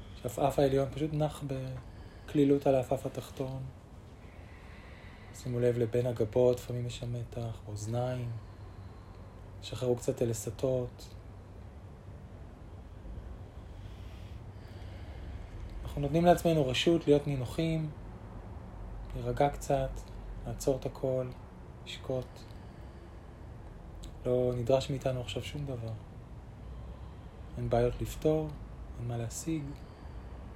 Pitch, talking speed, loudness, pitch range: 115 Hz, 85 wpm, -32 LUFS, 95-130 Hz